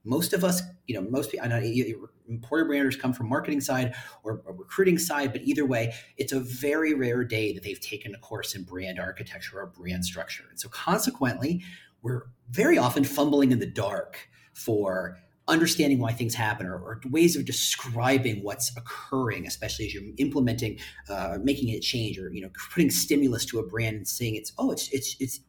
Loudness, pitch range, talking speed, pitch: -27 LUFS, 110-140 Hz, 195 wpm, 125 Hz